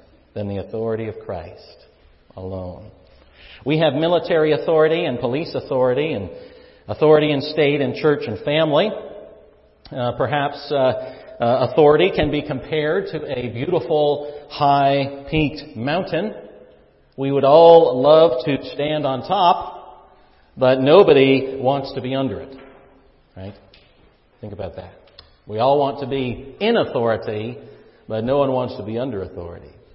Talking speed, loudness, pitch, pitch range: 140 wpm, -18 LUFS, 140 Hz, 125-150 Hz